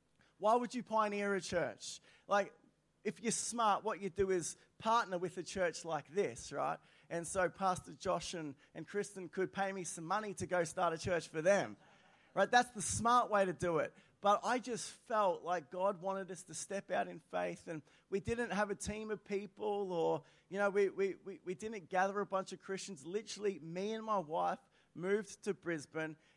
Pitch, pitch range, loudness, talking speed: 195 Hz, 175-205 Hz, -38 LUFS, 205 wpm